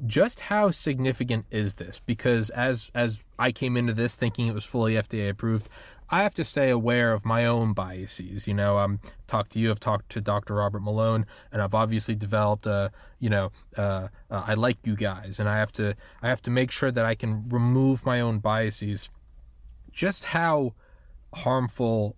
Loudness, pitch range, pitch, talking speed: -26 LUFS, 105-120 Hz, 110 Hz, 190 wpm